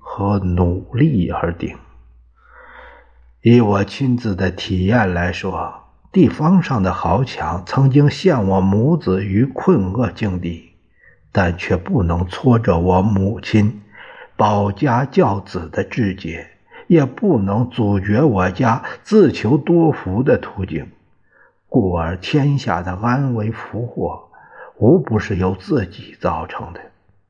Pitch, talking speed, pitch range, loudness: 100 Hz, 175 characters per minute, 90-125 Hz, -17 LUFS